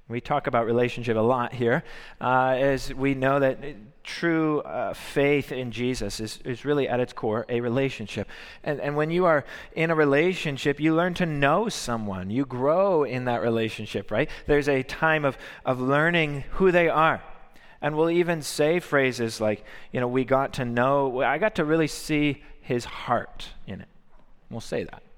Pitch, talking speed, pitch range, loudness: 140 Hz, 185 wpm, 125-150 Hz, -25 LUFS